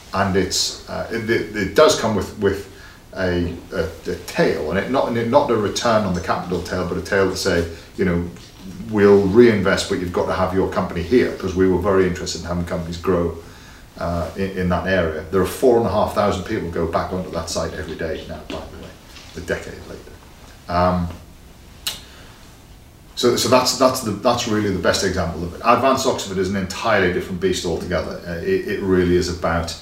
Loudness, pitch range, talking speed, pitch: -20 LUFS, 85-100 Hz, 210 wpm, 95 Hz